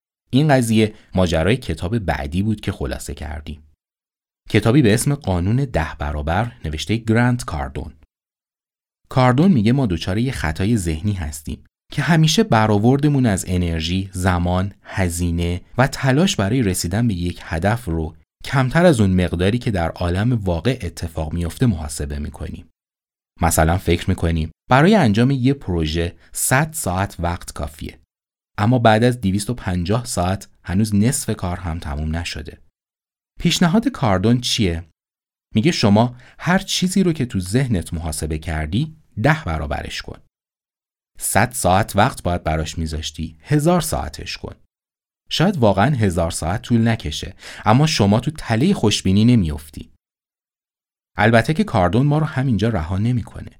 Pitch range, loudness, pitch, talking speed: 85-125 Hz, -19 LUFS, 95 Hz, 135 wpm